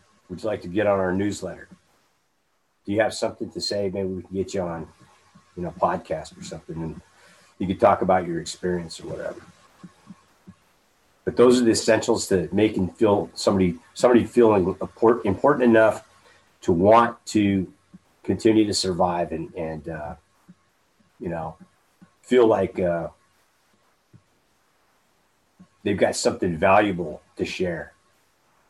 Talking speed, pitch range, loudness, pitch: 140 wpm, 90-110 Hz, -22 LUFS, 100 Hz